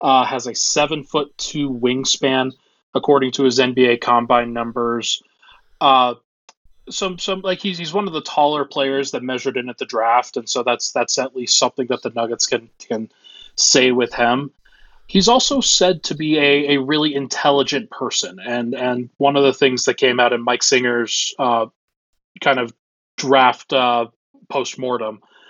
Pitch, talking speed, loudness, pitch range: 130 Hz, 175 wpm, -18 LUFS, 125-145 Hz